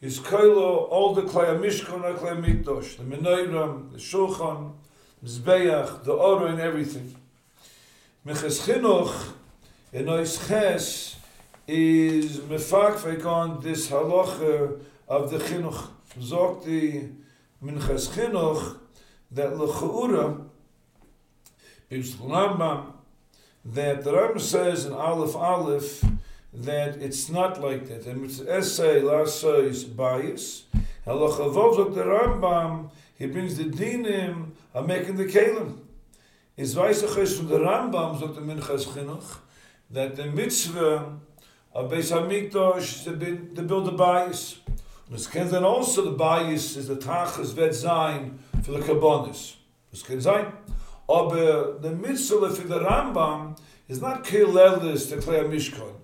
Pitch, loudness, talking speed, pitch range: 155 Hz, -25 LUFS, 135 wpm, 140-180 Hz